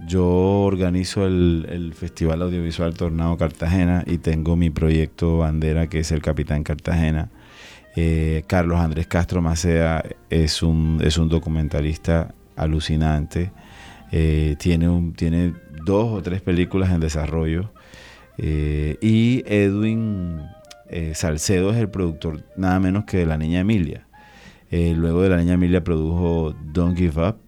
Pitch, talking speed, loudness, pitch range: 85 Hz, 140 wpm, -21 LUFS, 80-90 Hz